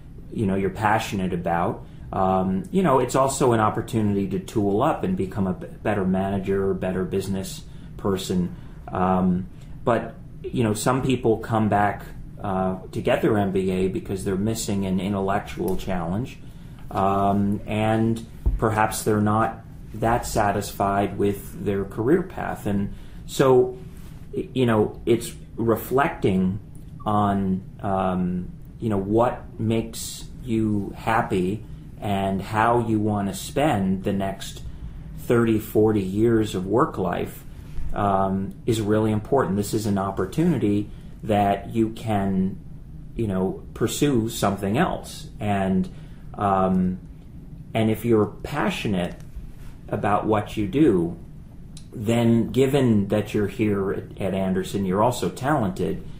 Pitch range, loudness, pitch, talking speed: 95-115 Hz, -24 LUFS, 105 Hz, 125 wpm